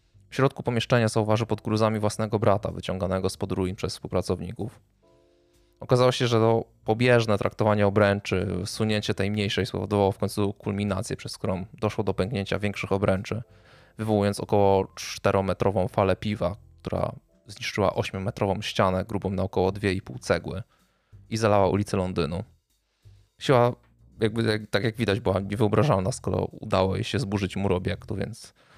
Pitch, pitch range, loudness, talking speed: 100 Hz, 95-110 Hz, -26 LUFS, 140 wpm